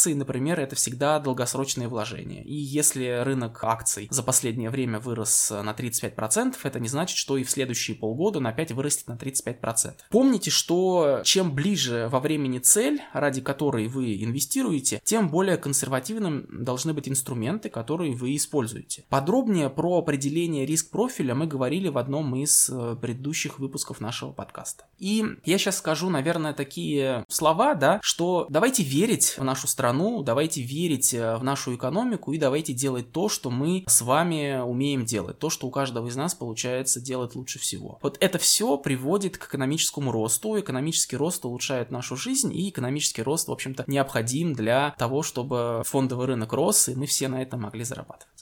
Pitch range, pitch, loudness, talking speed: 125-160 Hz, 135 Hz, -25 LUFS, 165 wpm